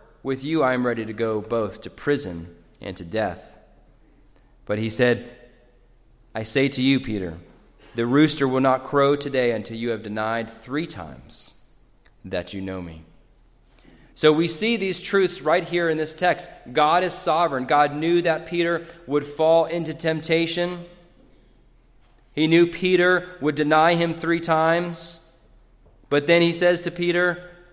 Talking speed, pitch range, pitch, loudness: 155 wpm, 115-170 Hz, 145 Hz, -22 LUFS